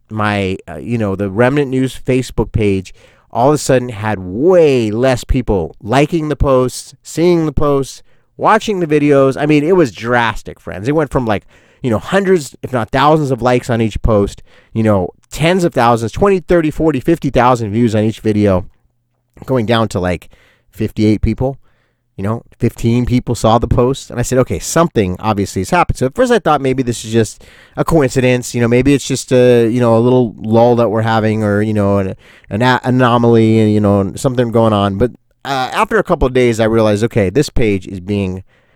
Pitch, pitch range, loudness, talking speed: 120 Hz, 110-135 Hz, -14 LUFS, 205 wpm